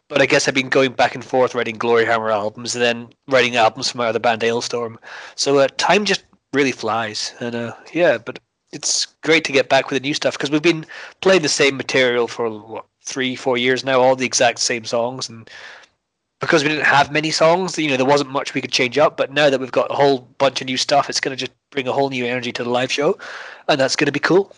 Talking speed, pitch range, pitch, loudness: 255 wpm, 120-140 Hz, 130 Hz, -18 LUFS